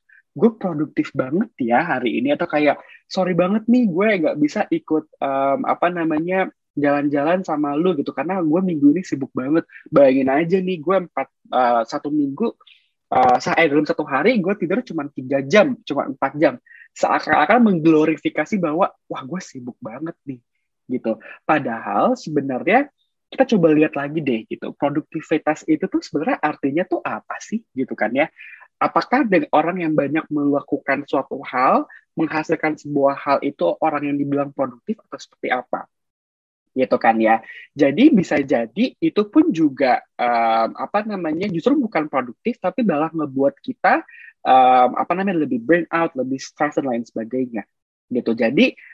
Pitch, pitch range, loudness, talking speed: 160 Hz, 140-205 Hz, -19 LUFS, 155 wpm